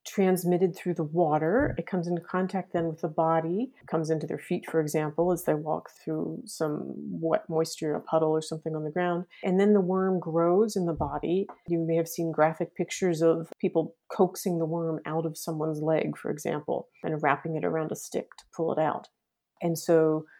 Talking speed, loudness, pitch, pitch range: 205 wpm, -28 LUFS, 165 Hz, 160-180 Hz